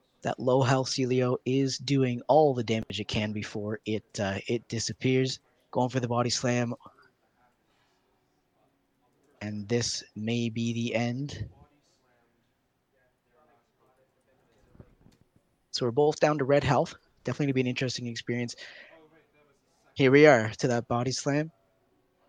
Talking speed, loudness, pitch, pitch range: 125 wpm, -28 LUFS, 125 Hz, 115-130 Hz